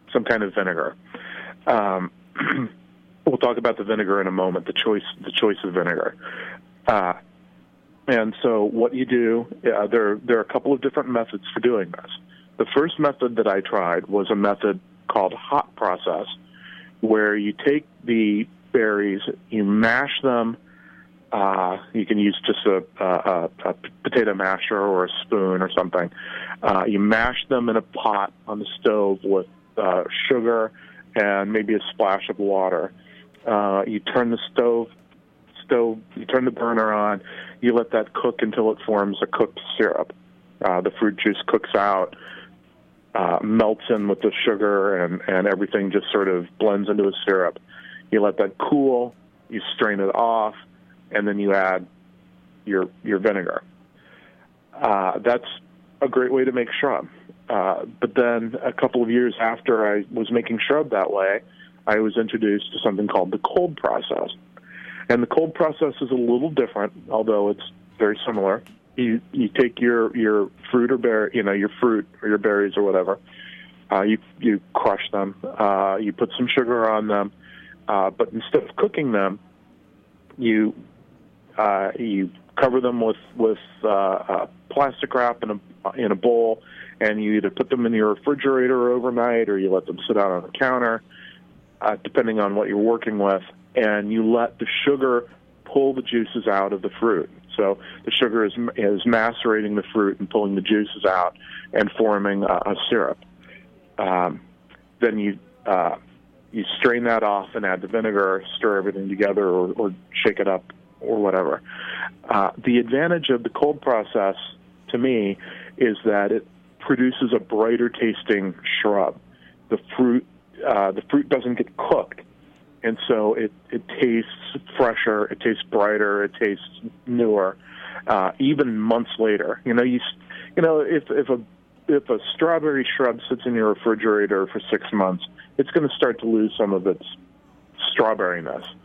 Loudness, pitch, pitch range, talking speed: -22 LUFS, 105 Hz, 100-120 Hz, 170 wpm